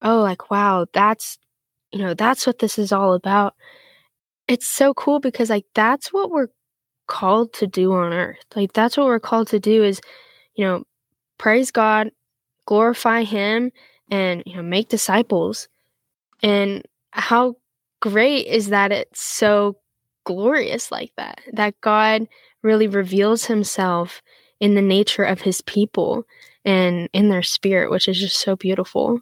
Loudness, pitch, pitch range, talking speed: -19 LUFS, 210 Hz, 190-230 Hz, 150 wpm